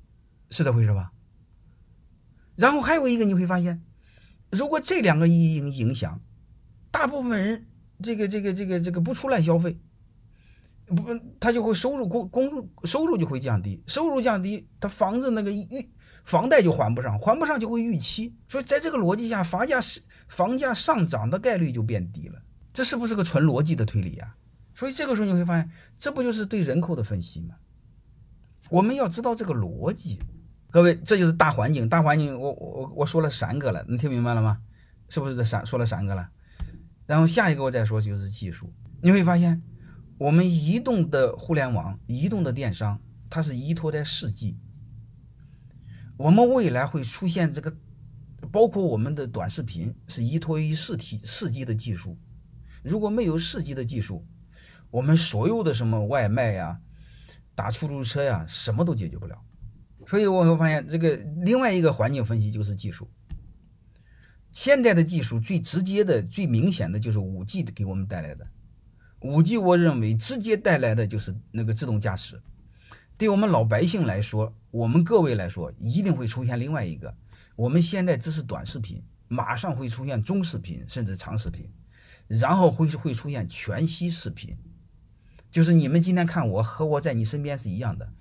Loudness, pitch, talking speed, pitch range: -25 LUFS, 145 Hz, 280 characters per minute, 110-180 Hz